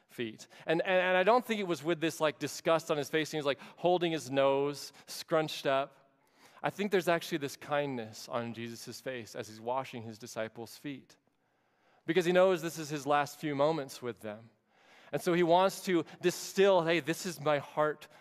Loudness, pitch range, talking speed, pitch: -32 LUFS, 135-175 Hz, 205 wpm, 150 Hz